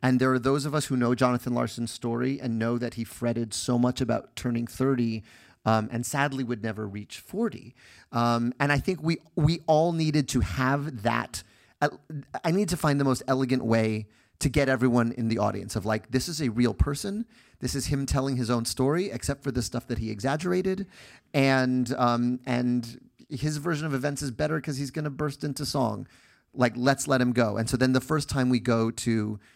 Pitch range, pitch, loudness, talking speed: 120-140 Hz, 130 Hz, -27 LUFS, 215 wpm